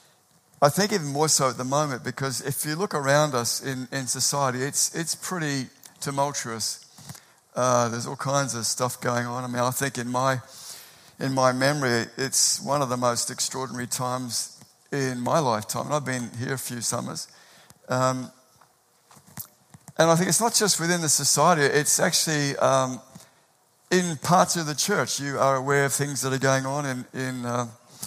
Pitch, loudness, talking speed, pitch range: 135 Hz, -24 LUFS, 180 wpm, 125-150 Hz